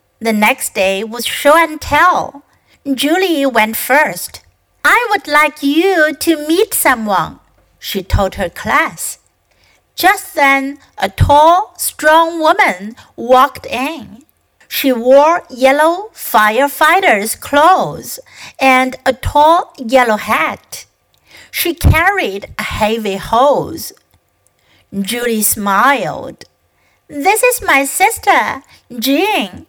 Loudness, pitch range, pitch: -12 LUFS, 240-330 Hz, 280 Hz